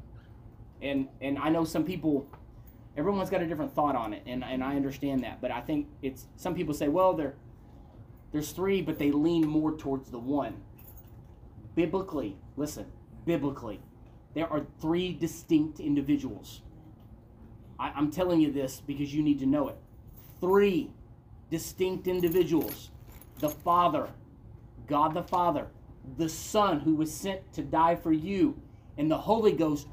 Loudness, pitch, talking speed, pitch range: -30 LUFS, 145 Hz, 150 wpm, 120-165 Hz